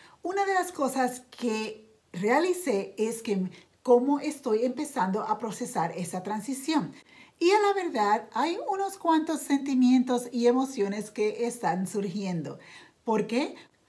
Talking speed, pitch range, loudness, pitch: 130 wpm, 215-290 Hz, -28 LUFS, 245 Hz